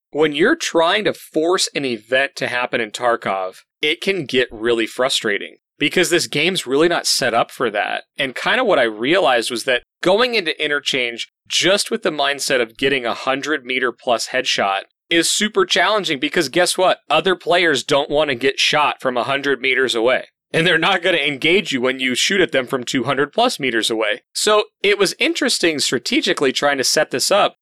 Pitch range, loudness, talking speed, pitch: 130-175 Hz, -17 LUFS, 200 wpm, 145 Hz